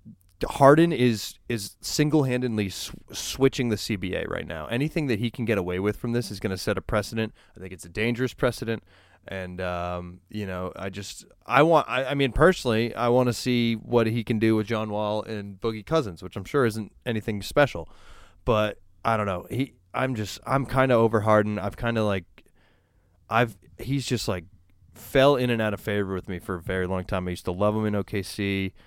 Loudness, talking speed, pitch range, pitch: -25 LUFS, 215 wpm, 95-120 Hz, 110 Hz